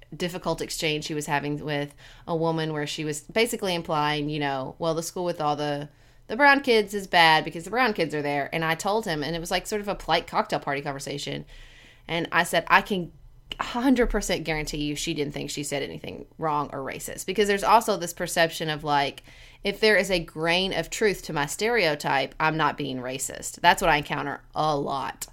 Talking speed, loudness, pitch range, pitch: 215 wpm, -25 LUFS, 145-185 Hz, 160 Hz